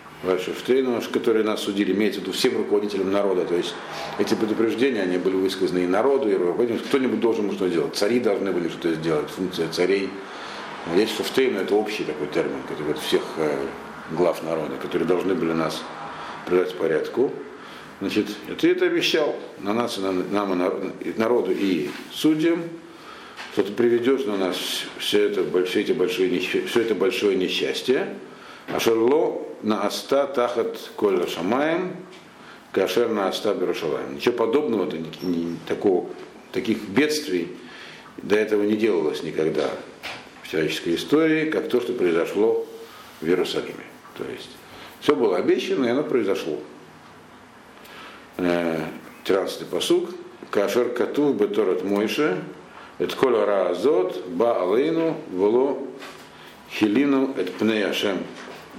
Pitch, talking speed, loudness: 135 Hz, 130 wpm, -23 LUFS